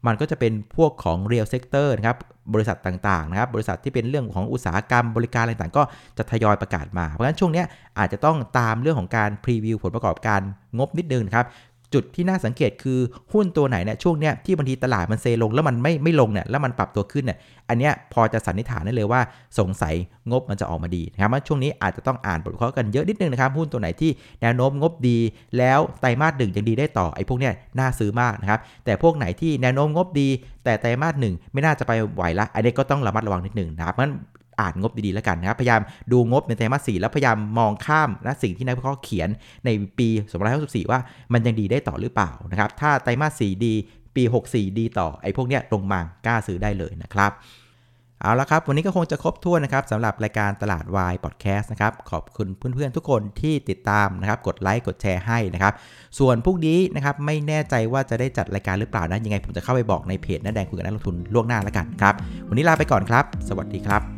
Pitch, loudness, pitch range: 115 Hz, -22 LUFS, 100-135 Hz